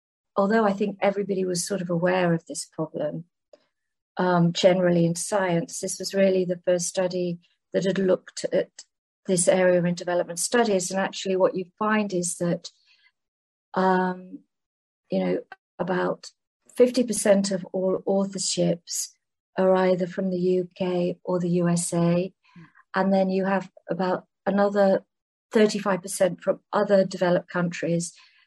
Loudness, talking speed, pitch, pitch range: -24 LUFS, 135 wpm, 185 Hz, 175-195 Hz